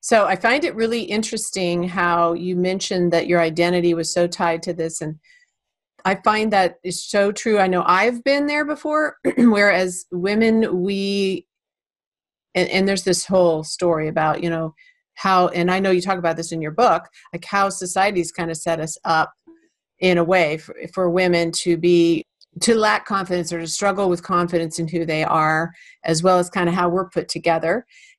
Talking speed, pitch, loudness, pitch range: 190 wpm, 180 Hz, -19 LUFS, 170-200 Hz